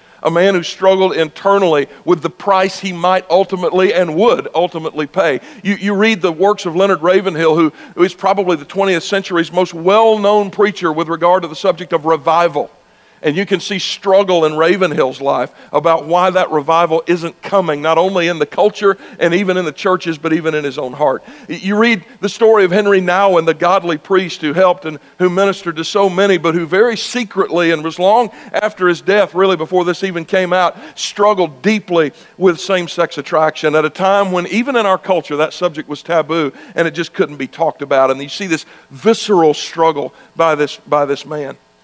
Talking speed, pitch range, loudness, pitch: 200 wpm, 165-195 Hz, -14 LUFS, 180 Hz